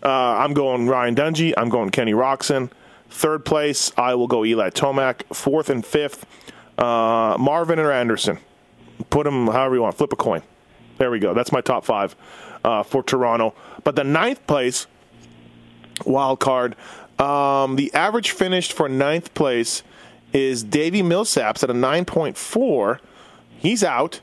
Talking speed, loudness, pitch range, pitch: 155 wpm, -20 LUFS, 120-145 Hz, 135 Hz